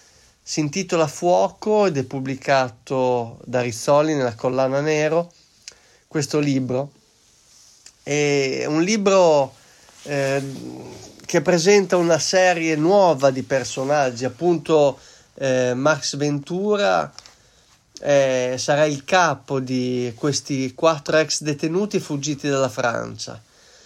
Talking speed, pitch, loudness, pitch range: 100 wpm, 145 Hz, -20 LUFS, 130-165 Hz